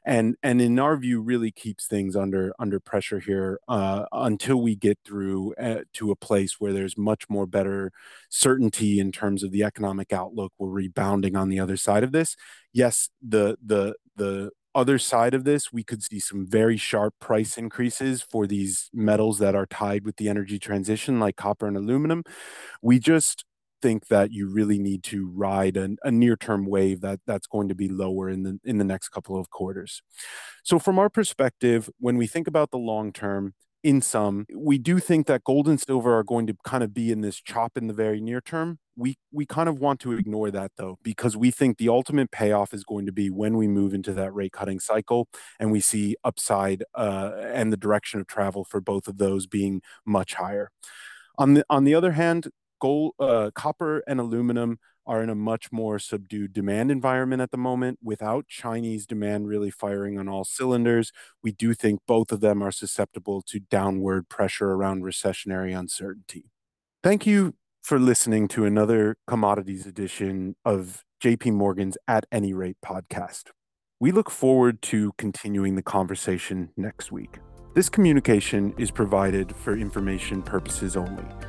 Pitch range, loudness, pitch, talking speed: 100-120 Hz, -25 LUFS, 105 Hz, 185 wpm